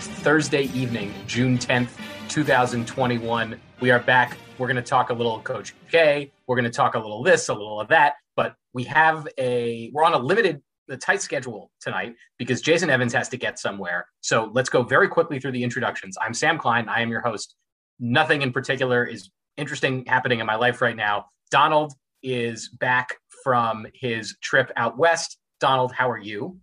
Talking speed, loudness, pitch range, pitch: 190 wpm, -22 LUFS, 120-140 Hz, 125 Hz